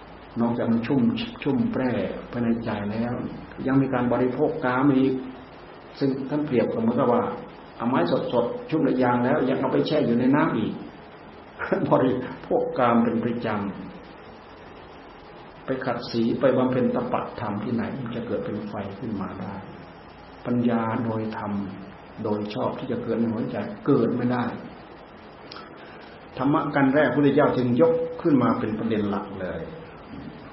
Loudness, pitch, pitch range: -24 LUFS, 120 Hz, 105-130 Hz